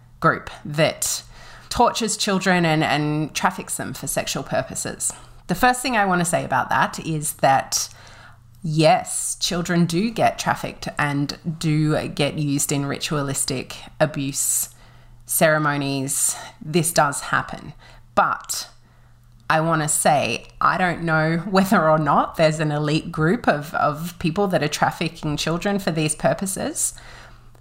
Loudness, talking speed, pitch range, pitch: -21 LUFS, 135 wpm, 145-180 Hz, 155 Hz